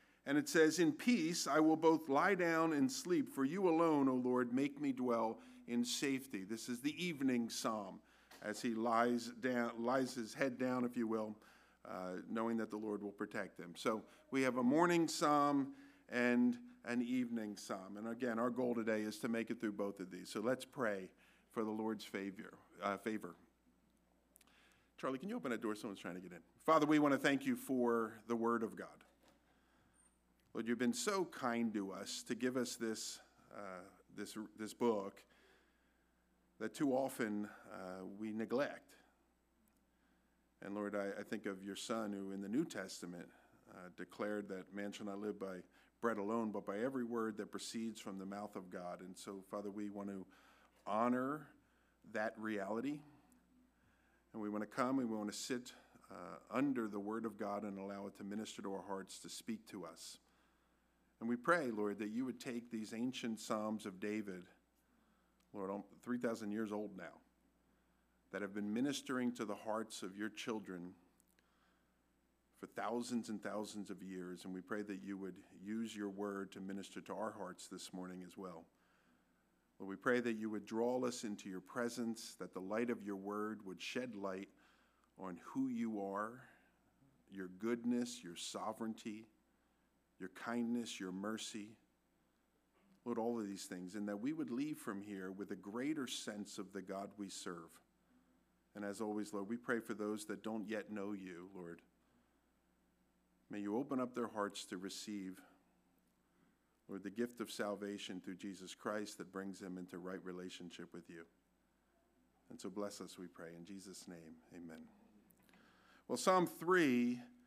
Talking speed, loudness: 180 wpm, -41 LUFS